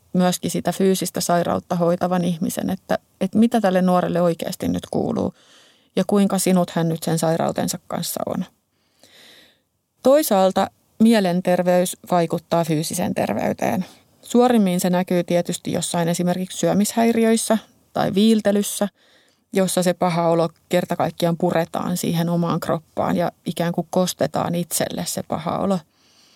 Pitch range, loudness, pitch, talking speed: 175-200 Hz, -21 LUFS, 180 Hz, 125 wpm